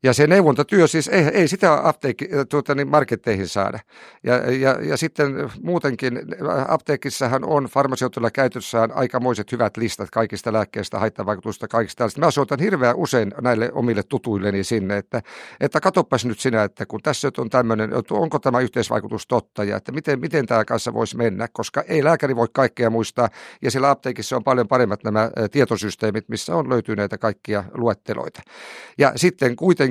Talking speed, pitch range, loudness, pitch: 160 wpm, 115-140 Hz, -21 LUFS, 125 Hz